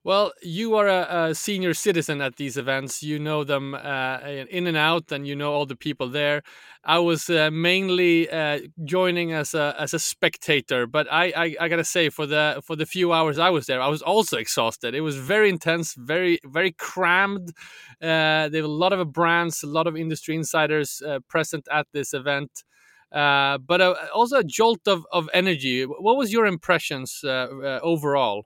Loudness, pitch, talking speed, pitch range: -23 LUFS, 160 Hz, 200 wpm, 145-175 Hz